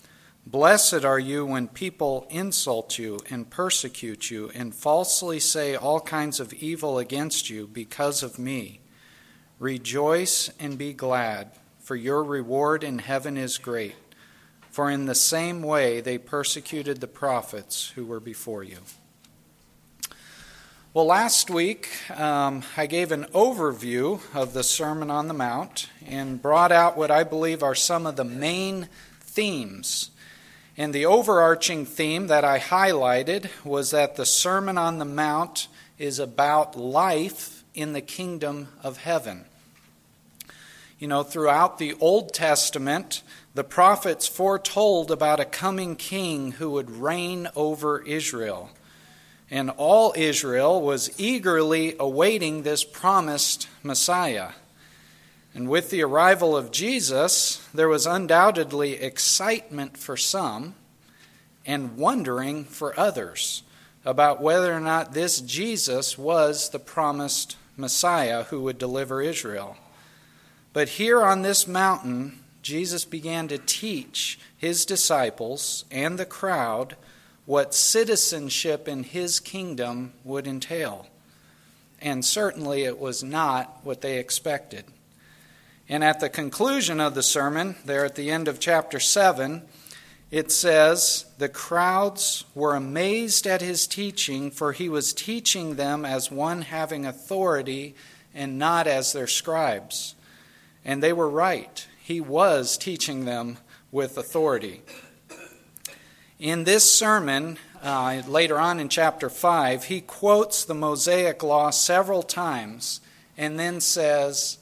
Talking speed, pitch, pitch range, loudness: 130 wpm, 150 Hz, 135-170 Hz, -23 LUFS